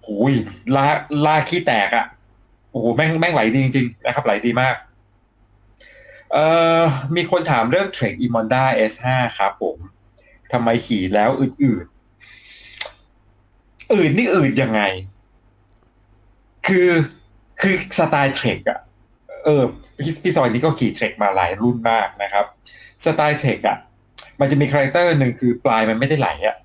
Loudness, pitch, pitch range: -18 LUFS, 125 Hz, 110-150 Hz